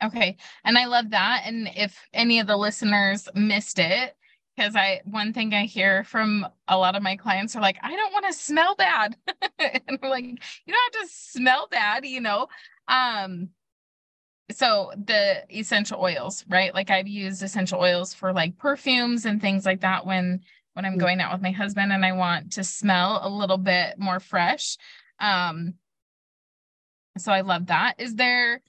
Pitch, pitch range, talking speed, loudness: 205 Hz, 190-245 Hz, 180 wpm, -23 LUFS